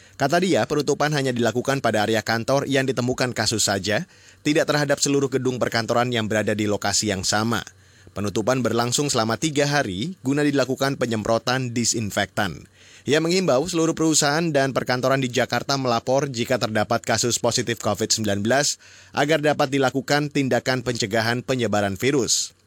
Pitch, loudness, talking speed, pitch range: 125 Hz, -22 LUFS, 140 wpm, 110-140 Hz